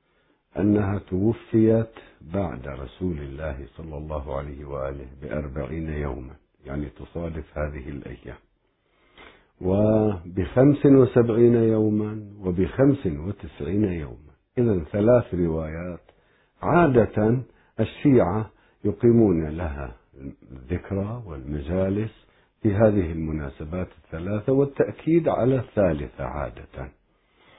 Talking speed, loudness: 85 wpm, -24 LUFS